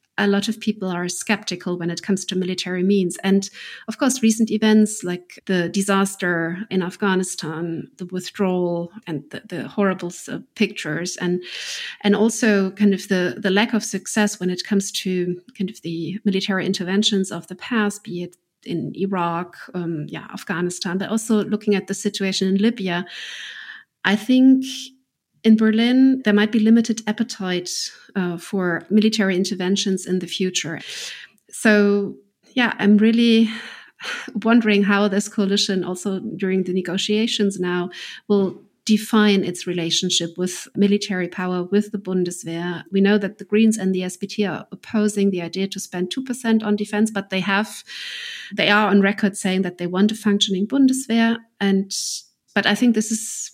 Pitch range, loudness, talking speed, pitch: 180-215 Hz, -21 LUFS, 160 wpm, 195 Hz